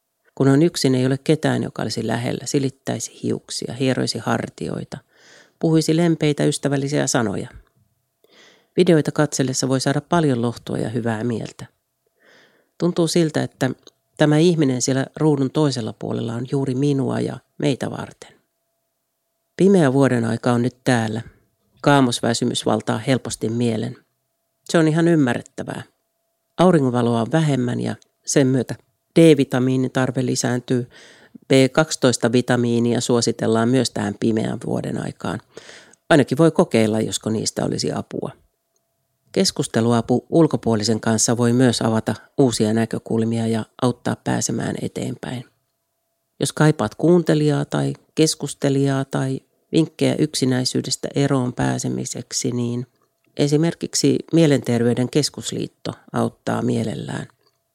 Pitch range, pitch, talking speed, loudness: 115-145 Hz, 130 Hz, 110 wpm, -20 LUFS